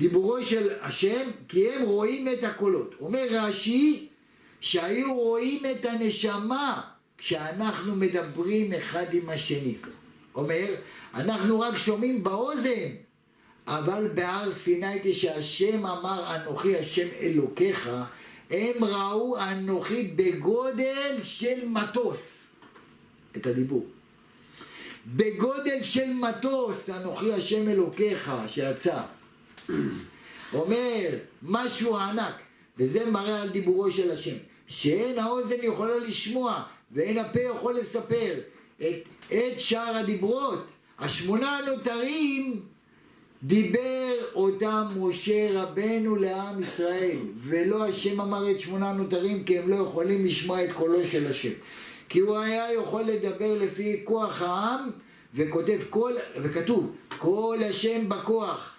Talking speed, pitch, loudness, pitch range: 105 wpm, 210 Hz, -27 LUFS, 185-235 Hz